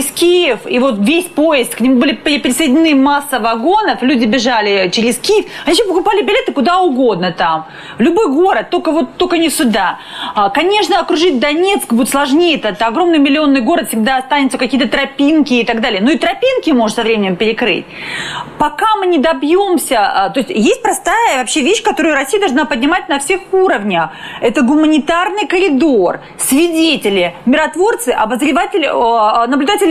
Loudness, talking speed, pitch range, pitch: -12 LUFS, 155 wpm, 250-355 Hz, 295 Hz